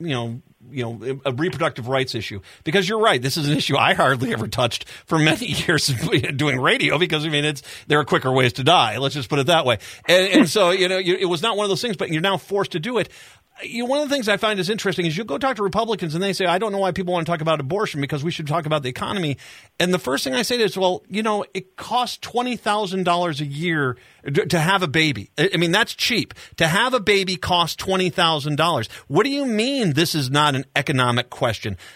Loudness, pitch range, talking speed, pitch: -20 LUFS, 140-195 Hz, 255 wpm, 170 Hz